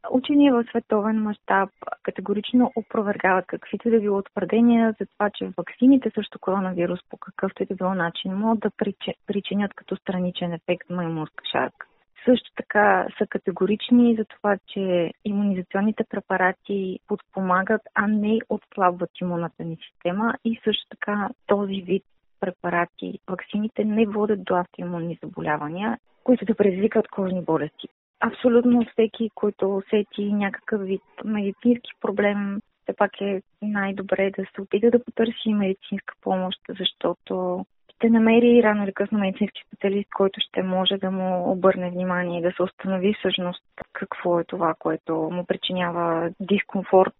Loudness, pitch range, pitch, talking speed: -24 LUFS, 185-220 Hz, 200 Hz, 140 wpm